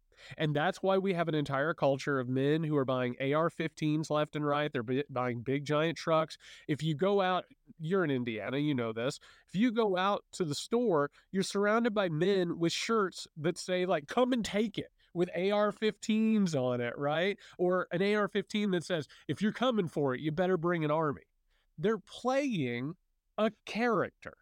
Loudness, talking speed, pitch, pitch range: -32 LUFS, 195 wpm, 175 Hz, 145-200 Hz